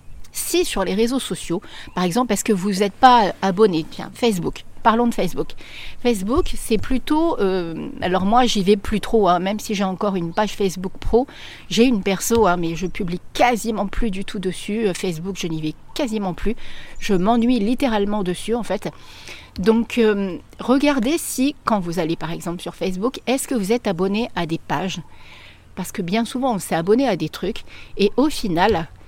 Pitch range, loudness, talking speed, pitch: 180-230 Hz, -20 LUFS, 190 wpm, 205 Hz